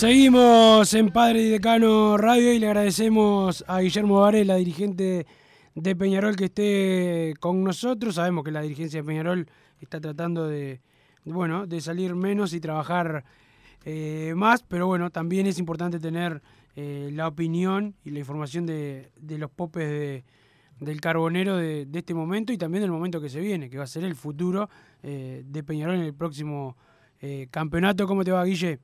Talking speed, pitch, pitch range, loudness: 175 wpm, 170 Hz, 150-195 Hz, -23 LUFS